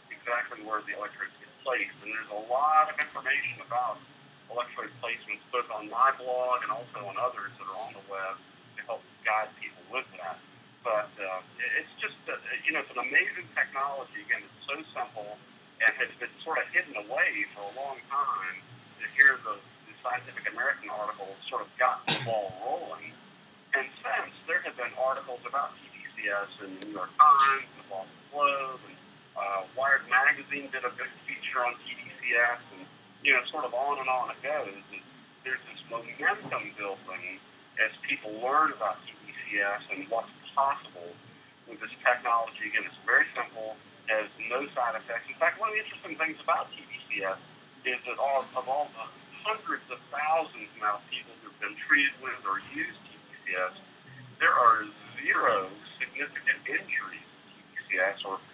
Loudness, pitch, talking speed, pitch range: -30 LUFS, 125 Hz, 170 wpm, 105-135 Hz